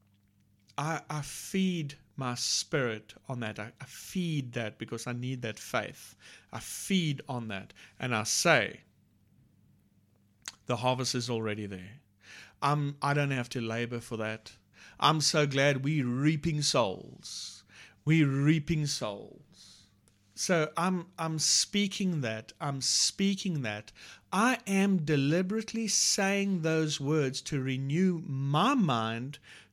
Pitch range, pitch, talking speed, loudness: 115-160 Hz, 135 Hz, 125 wpm, -30 LUFS